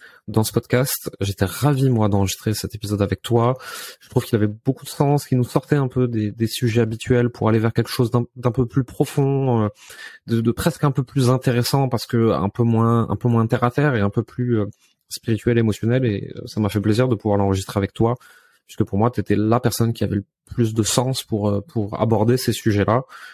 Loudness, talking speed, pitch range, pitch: -20 LUFS, 235 wpm, 105-125 Hz, 115 Hz